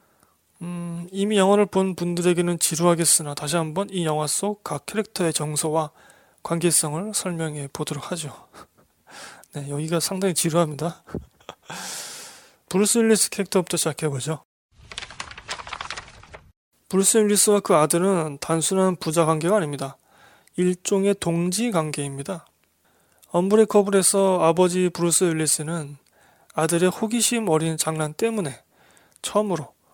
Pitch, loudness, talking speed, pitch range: 175 Hz, -22 LUFS, 285 characters per minute, 160-195 Hz